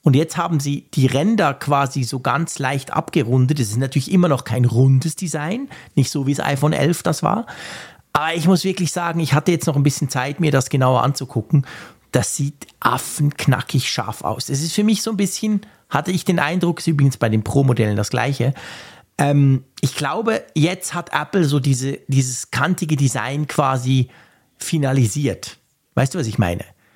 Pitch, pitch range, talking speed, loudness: 145 Hz, 130-165 Hz, 185 wpm, -19 LUFS